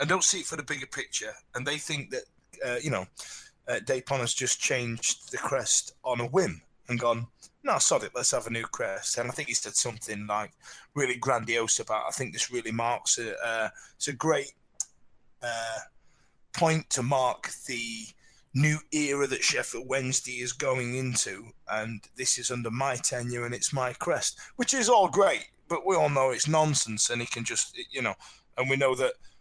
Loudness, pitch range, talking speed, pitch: -28 LUFS, 115-140 Hz, 200 wpm, 125 Hz